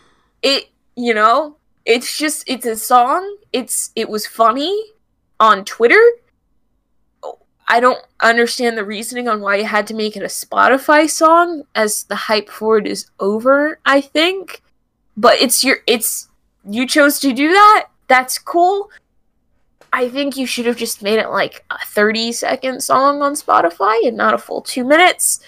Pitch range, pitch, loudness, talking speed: 225-310 Hz, 255 Hz, -14 LUFS, 165 wpm